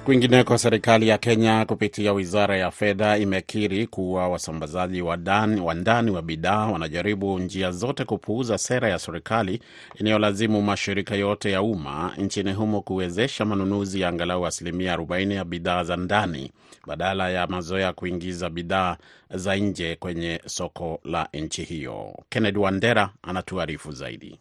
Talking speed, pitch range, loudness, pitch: 140 wpm, 90-105 Hz, -24 LUFS, 95 Hz